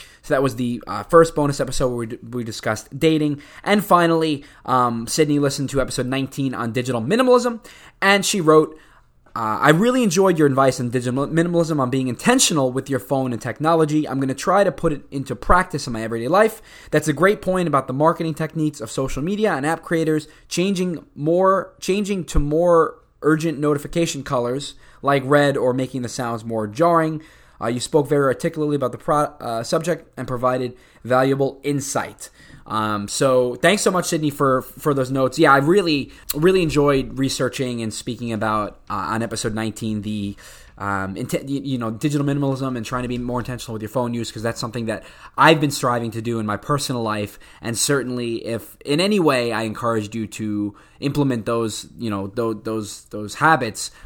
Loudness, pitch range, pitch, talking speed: -20 LUFS, 120-155 Hz, 135 Hz, 190 wpm